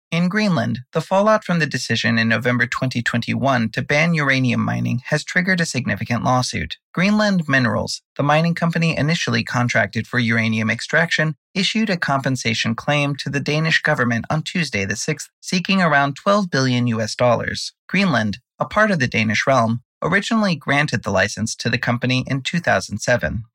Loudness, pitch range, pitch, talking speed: -19 LUFS, 115-165 Hz, 135 Hz, 160 wpm